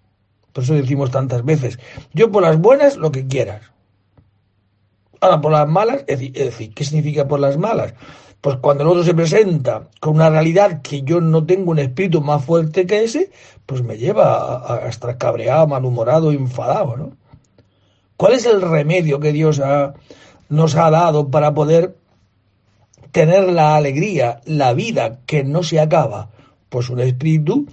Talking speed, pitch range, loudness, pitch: 165 wpm, 125-160 Hz, -16 LUFS, 150 Hz